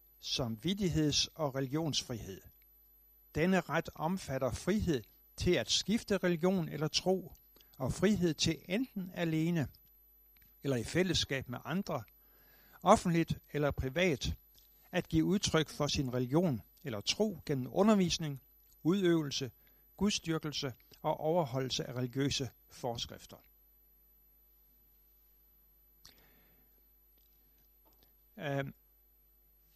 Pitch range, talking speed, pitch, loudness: 130-175 Hz, 90 wpm, 155 Hz, -34 LUFS